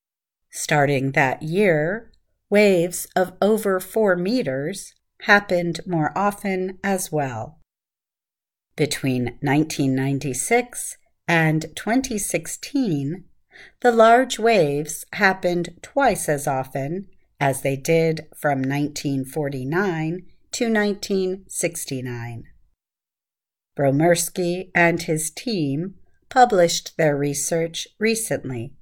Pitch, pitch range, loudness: 170 Hz, 145-195 Hz, -21 LUFS